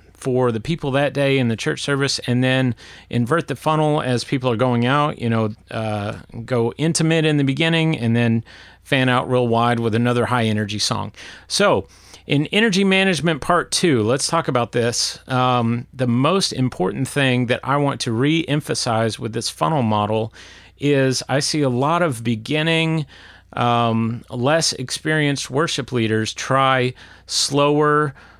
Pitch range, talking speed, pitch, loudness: 115-145 Hz, 165 wpm, 130 Hz, -19 LUFS